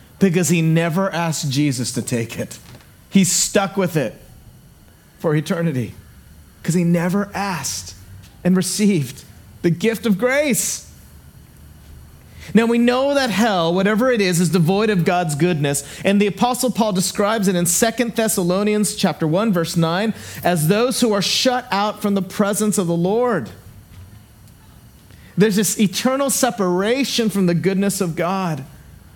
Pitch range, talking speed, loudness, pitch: 145-210 Hz, 145 wpm, -18 LUFS, 185 Hz